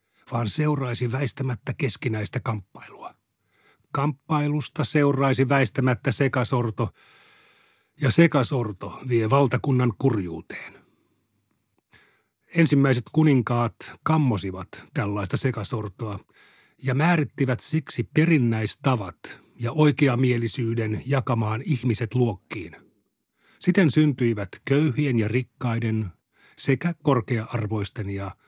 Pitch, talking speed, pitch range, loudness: 130 Hz, 75 wpm, 115-140 Hz, -24 LUFS